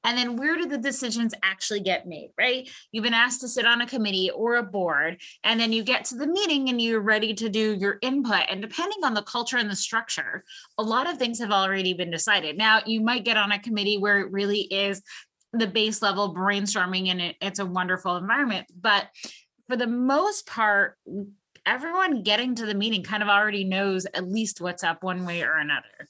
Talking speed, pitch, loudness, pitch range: 215 wpm, 215 Hz, -24 LUFS, 195-240 Hz